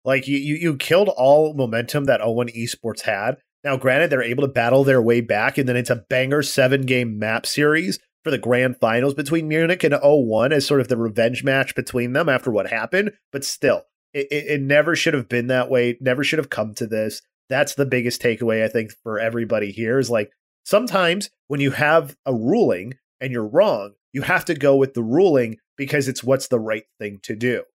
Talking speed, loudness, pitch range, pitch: 215 wpm, -20 LUFS, 120-145 Hz, 130 Hz